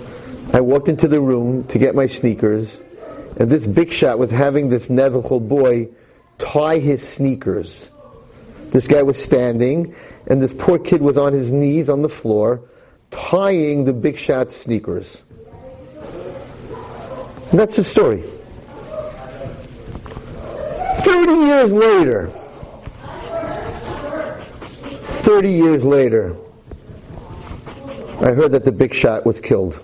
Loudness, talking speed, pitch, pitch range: -16 LUFS, 120 wpm, 140 Hz, 125-165 Hz